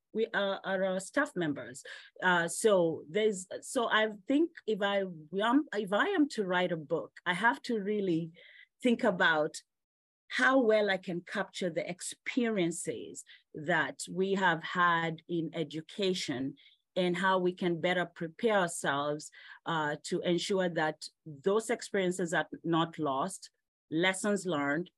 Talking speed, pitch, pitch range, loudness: 140 wpm, 185 Hz, 170-210 Hz, -31 LUFS